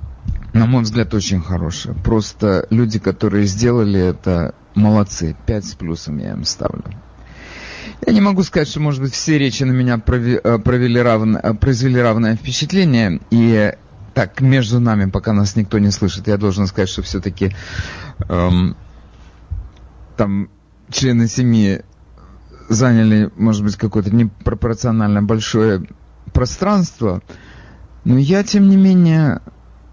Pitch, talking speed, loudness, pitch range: 110 Hz, 130 wpm, -16 LUFS, 95-120 Hz